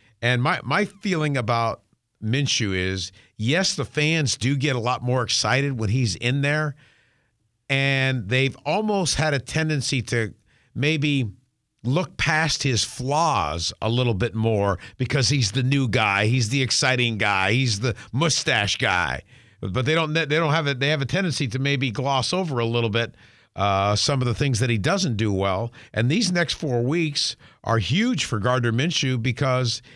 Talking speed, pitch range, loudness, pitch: 175 wpm, 115-145 Hz, -22 LUFS, 130 Hz